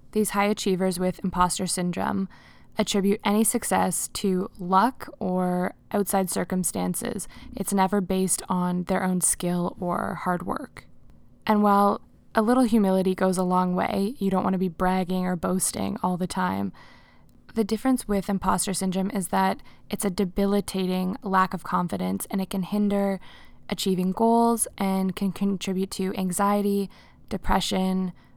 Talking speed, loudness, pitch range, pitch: 145 wpm, -25 LUFS, 185-200 Hz, 190 Hz